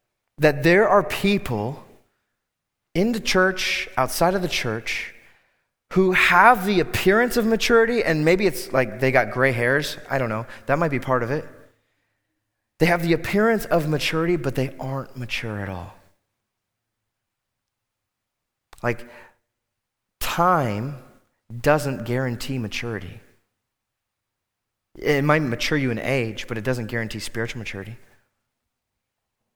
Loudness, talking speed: -21 LUFS, 130 wpm